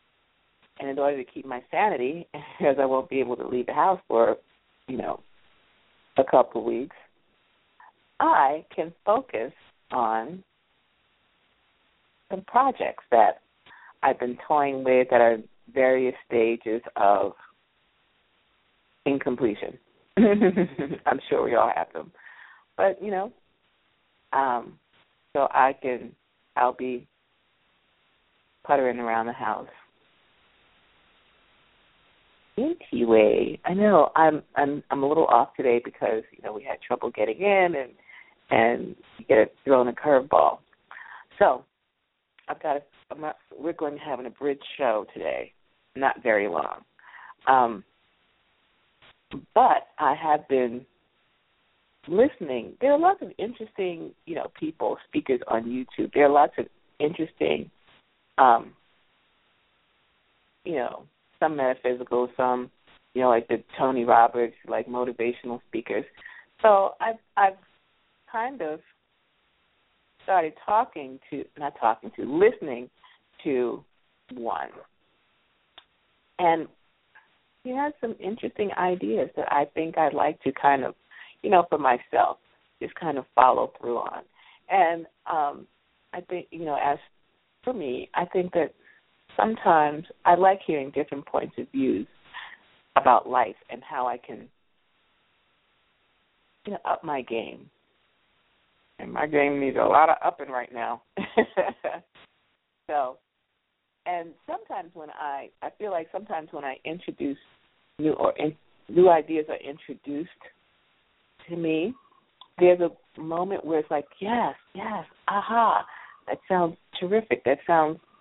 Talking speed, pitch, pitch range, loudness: 130 wpm, 150 Hz, 130-190 Hz, -25 LUFS